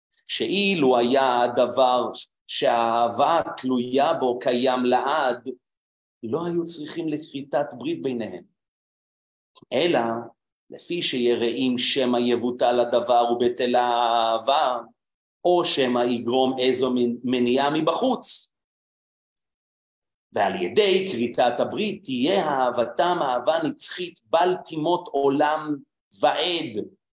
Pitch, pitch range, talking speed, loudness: 130 Hz, 120-165 Hz, 90 wpm, -23 LUFS